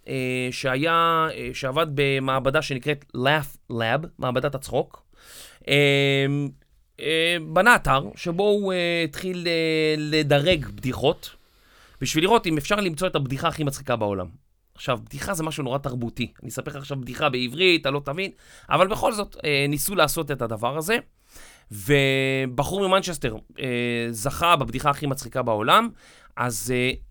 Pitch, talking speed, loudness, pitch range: 145 Hz, 145 wpm, -23 LUFS, 130-165 Hz